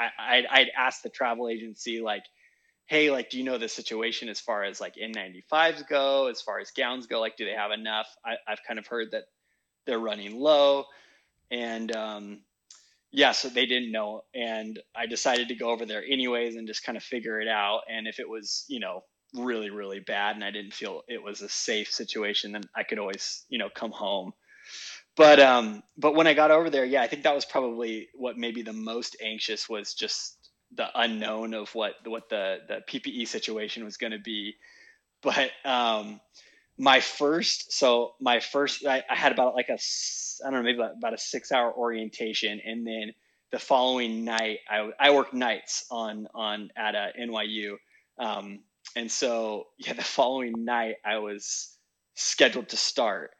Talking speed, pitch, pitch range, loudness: 190 wpm, 115 Hz, 110-125 Hz, -27 LUFS